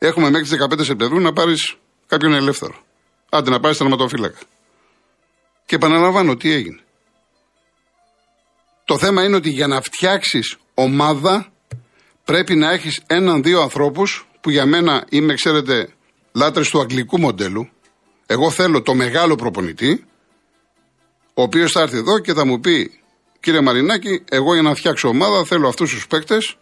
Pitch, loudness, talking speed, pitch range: 155 Hz, -16 LUFS, 145 wpm, 140-180 Hz